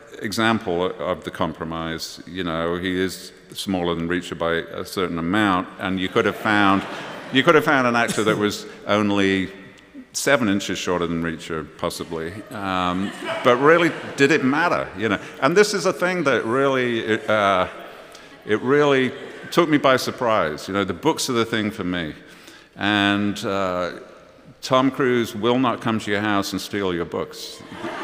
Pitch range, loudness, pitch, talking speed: 90-115 Hz, -21 LUFS, 100 Hz, 170 wpm